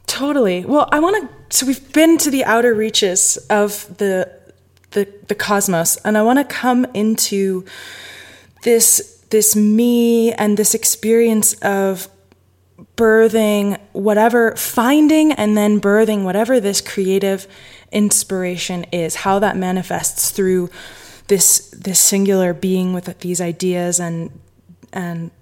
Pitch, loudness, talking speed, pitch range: 205 Hz, -15 LUFS, 125 wpm, 185-230 Hz